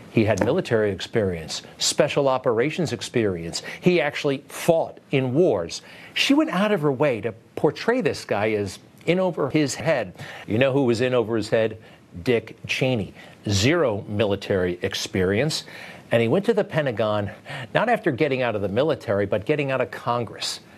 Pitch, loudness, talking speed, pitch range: 130 Hz, -23 LUFS, 170 wpm, 110-155 Hz